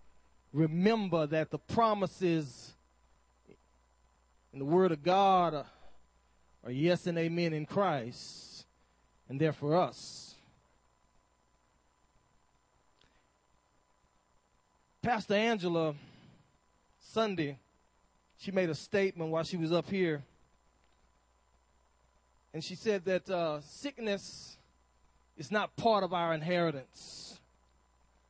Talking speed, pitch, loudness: 95 wpm, 150 Hz, -32 LUFS